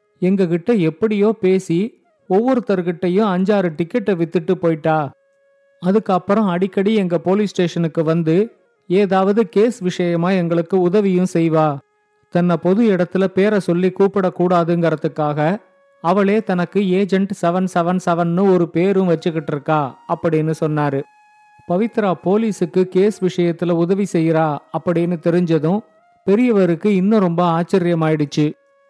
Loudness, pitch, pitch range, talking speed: -17 LUFS, 185 Hz, 170-205 Hz, 105 wpm